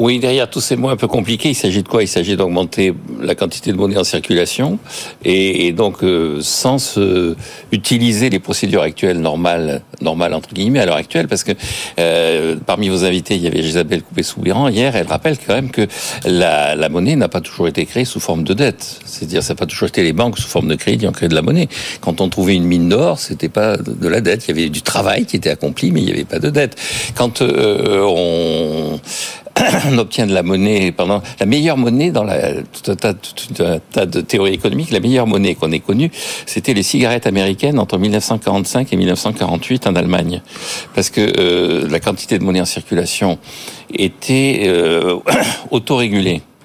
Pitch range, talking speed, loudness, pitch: 90-120 Hz, 210 wpm, -15 LUFS, 100 Hz